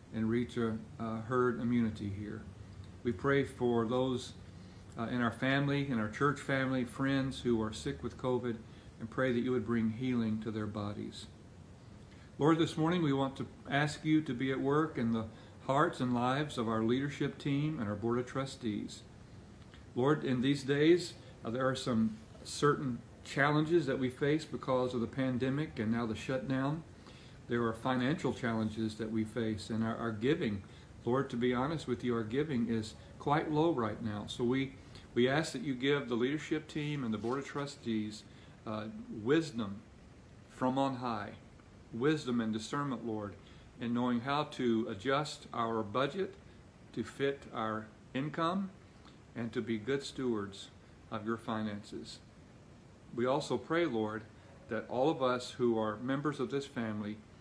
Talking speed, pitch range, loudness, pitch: 170 wpm, 110-135 Hz, -35 LUFS, 120 Hz